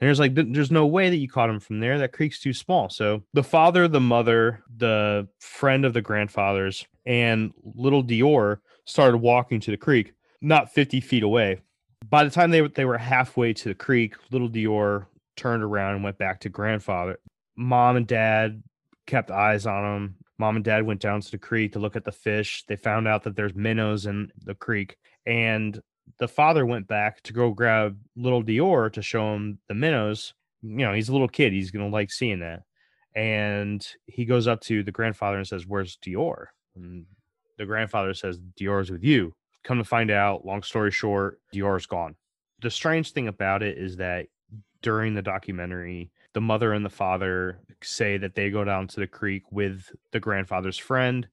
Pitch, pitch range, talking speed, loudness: 110 Hz, 100-120 Hz, 195 wpm, -24 LUFS